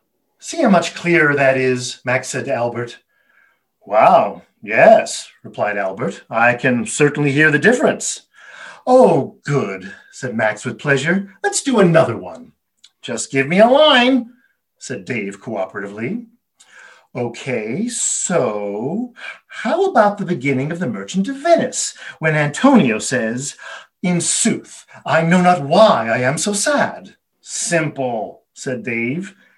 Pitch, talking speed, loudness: 175 Hz, 130 wpm, -16 LUFS